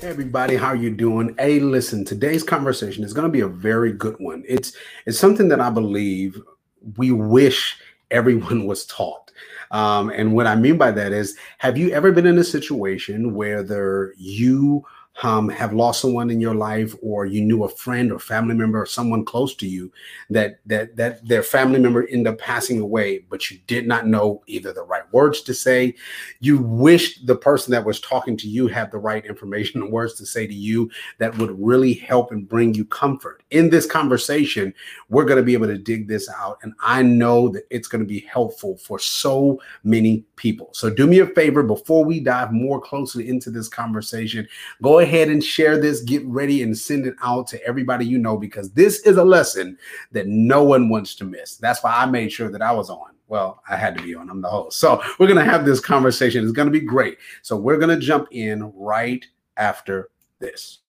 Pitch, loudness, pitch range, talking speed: 120 Hz, -19 LUFS, 110-135 Hz, 215 wpm